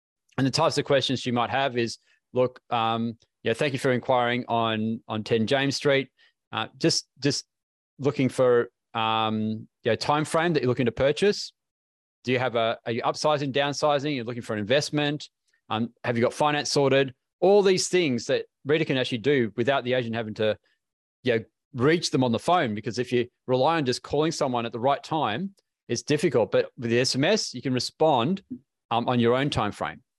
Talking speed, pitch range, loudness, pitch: 195 wpm, 115-150 Hz, -25 LUFS, 130 Hz